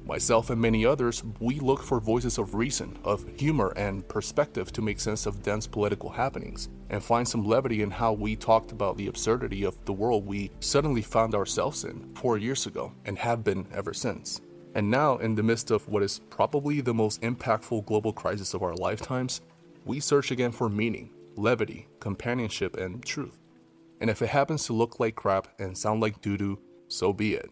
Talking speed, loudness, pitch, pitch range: 195 wpm, -28 LUFS, 110 Hz, 100-120 Hz